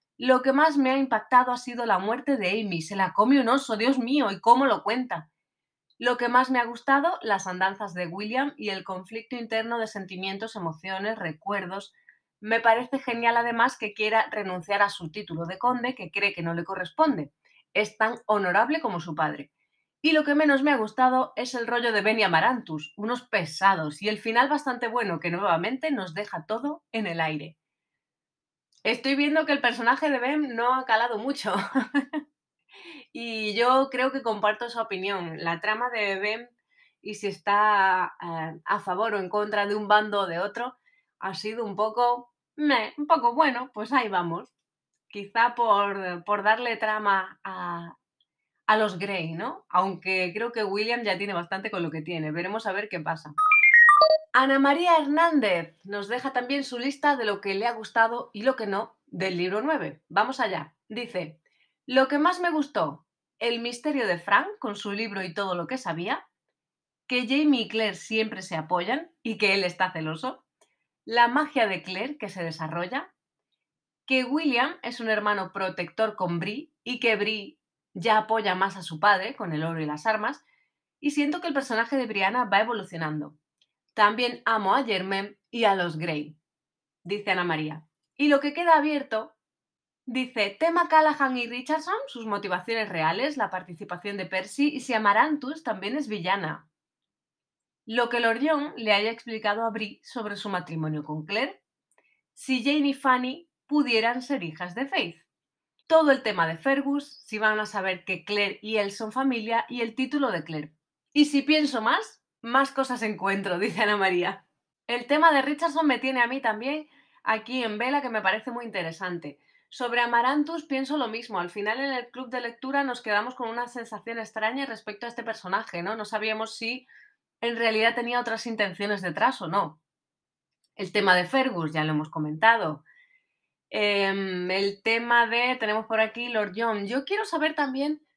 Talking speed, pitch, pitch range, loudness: 180 wpm, 220 Hz, 195-255 Hz, -26 LUFS